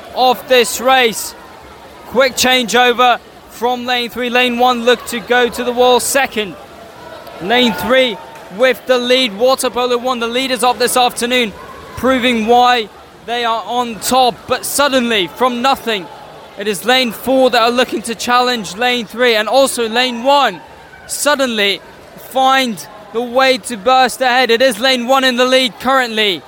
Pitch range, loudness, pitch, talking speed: 235-255 Hz, -13 LUFS, 245 Hz, 160 wpm